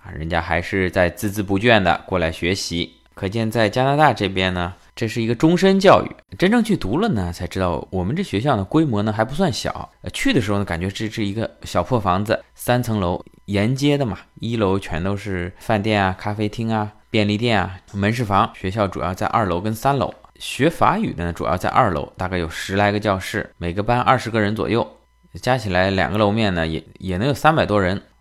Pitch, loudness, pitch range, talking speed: 100 Hz, -20 LUFS, 90-115 Hz, 315 characters per minute